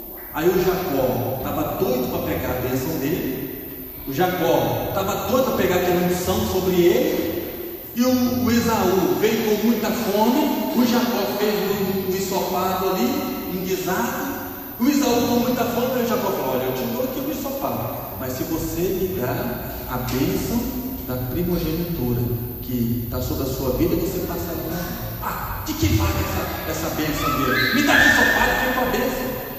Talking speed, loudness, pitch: 170 wpm, -22 LUFS, 185 Hz